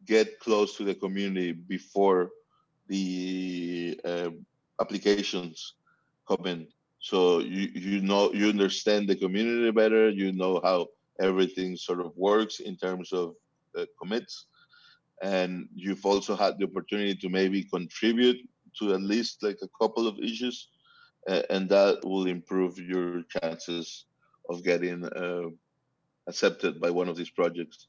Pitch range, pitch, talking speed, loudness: 90-105 Hz, 95 Hz, 140 wpm, -28 LUFS